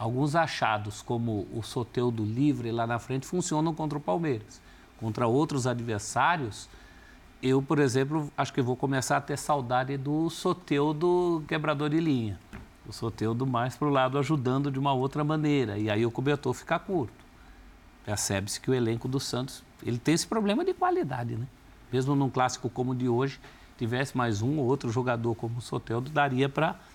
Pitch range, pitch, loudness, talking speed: 120-145 Hz, 130 Hz, -29 LUFS, 175 wpm